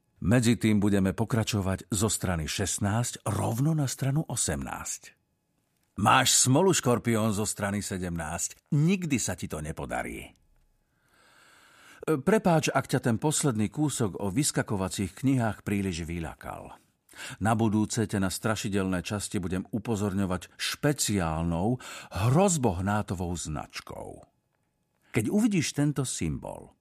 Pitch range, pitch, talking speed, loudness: 95-130 Hz, 110 Hz, 105 wpm, -28 LUFS